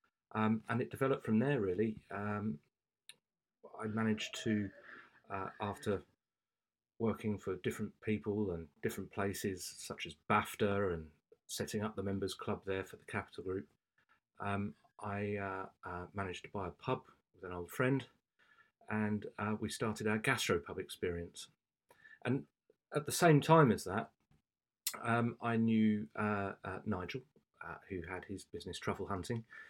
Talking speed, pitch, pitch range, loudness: 150 wpm, 105 Hz, 95-110 Hz, -38 LUFS